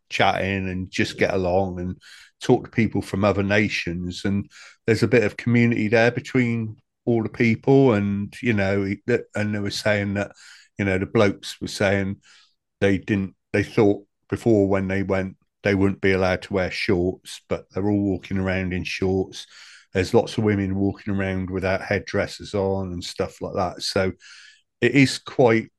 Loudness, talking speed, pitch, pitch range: -23 LUFS, 175 wpm, 100 Hz, 95-105 Hz